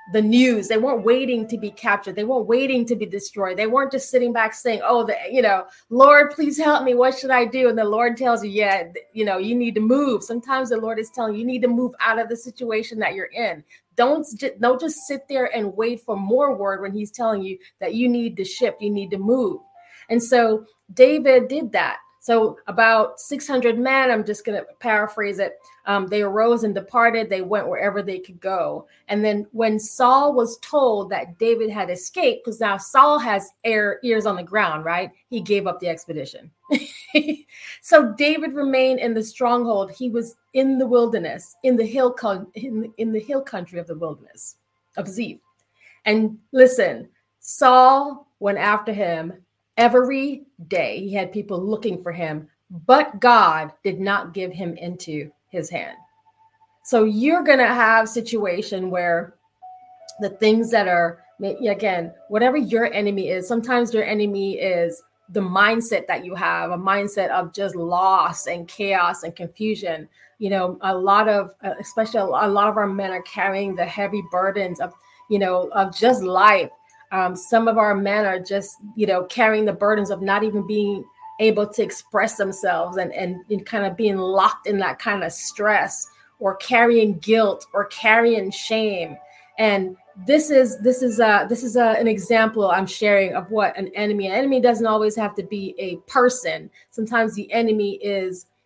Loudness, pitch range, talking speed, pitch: -20 LUFS, 195-245 Hz, 185 wpm, 215 Hz